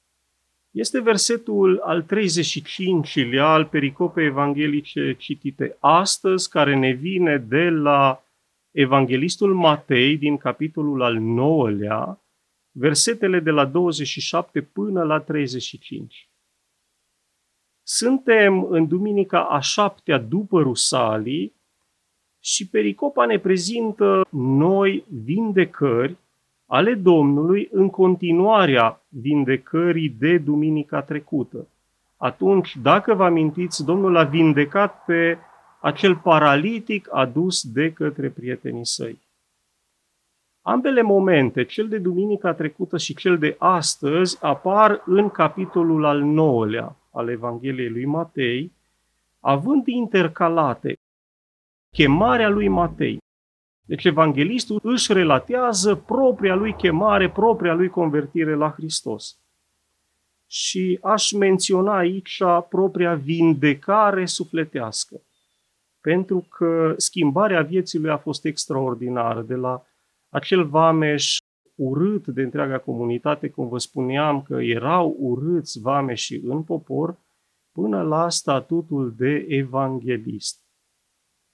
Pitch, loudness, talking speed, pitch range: 155 Hz, -20 LUFS, 100 wpm, 135-185 Hz